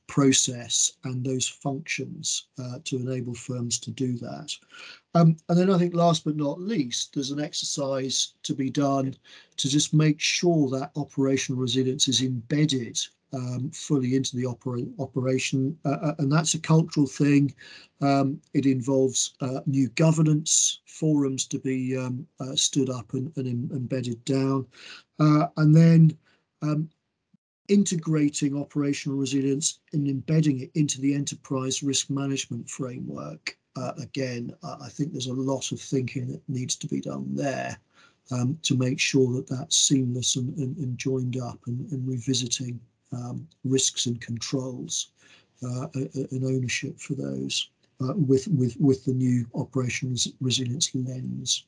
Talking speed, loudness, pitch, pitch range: 150 wpm, -26 LUFS, 135 Hz, 130-150 Hz